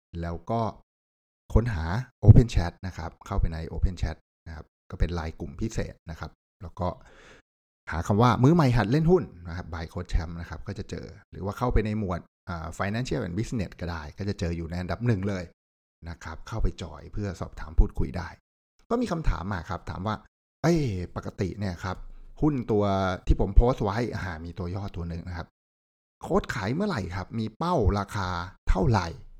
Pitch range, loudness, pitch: 85-105 Hz, -28 LUFS, 90 Hz